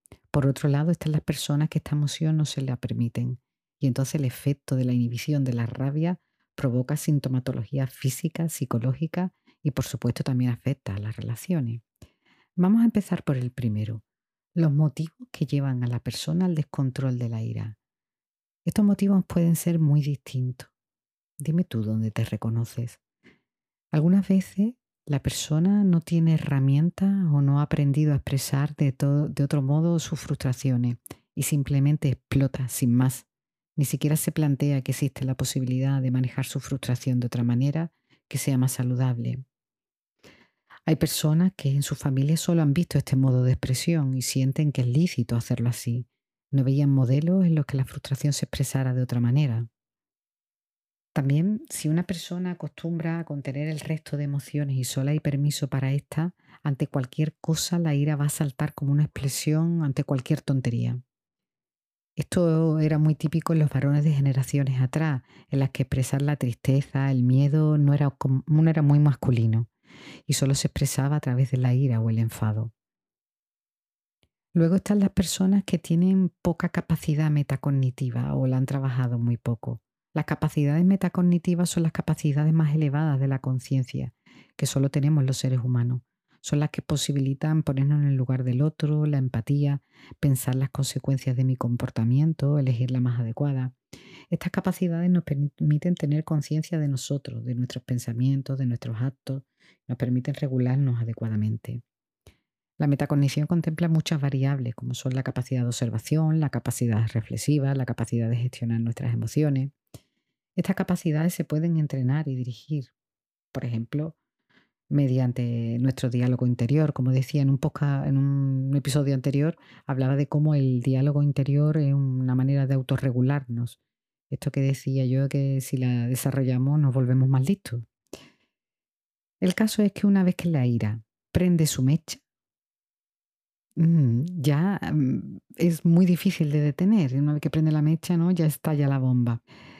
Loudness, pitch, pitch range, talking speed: -25 LUFS, 140 Hz, 130-155 Hz, 160 wpm